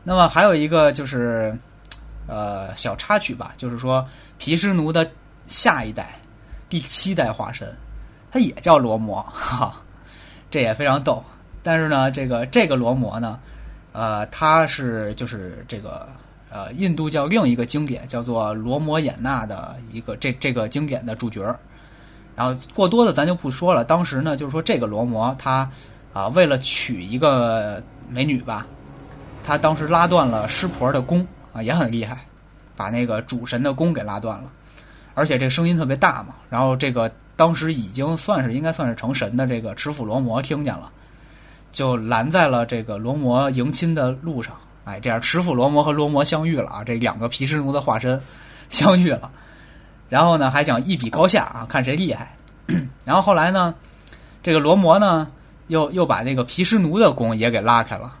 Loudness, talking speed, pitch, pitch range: -19 LUFS, 260 characters per minute, 135 Hz, 120-160 Hz